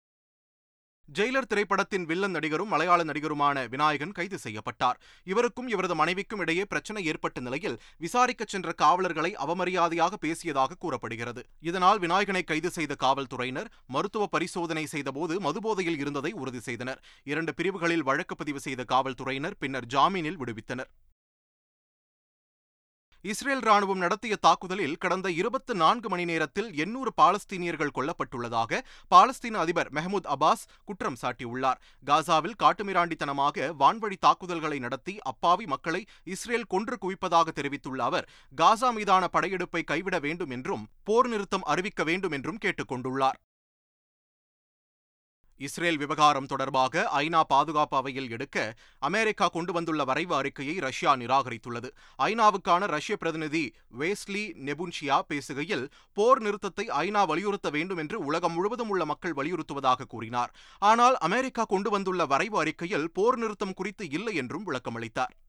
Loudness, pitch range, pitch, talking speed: -28 LUFS, 135-195 Hz, 165 Hz, 120 wpm